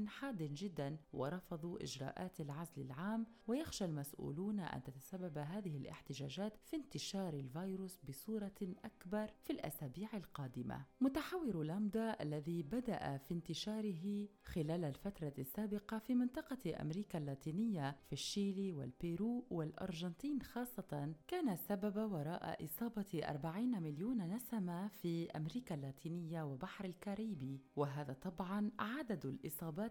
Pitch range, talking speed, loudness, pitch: 155-215 Hz, 110 wpm, -44 LUFS, 185 Hz